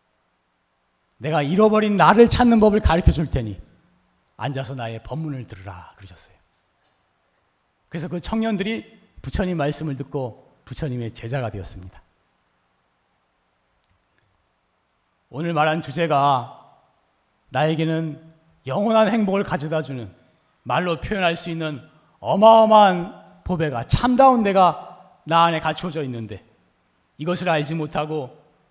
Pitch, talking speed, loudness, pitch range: 155 Hz, 255 characters per minute, -20 LUFS, 115-180 Hz